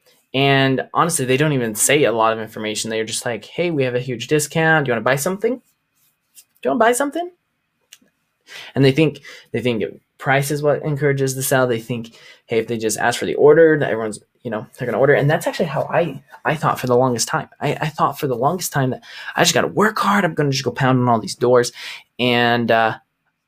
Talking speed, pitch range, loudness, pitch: 240 wpm, 120-155 Hz, -18 LUFS, 130 Hz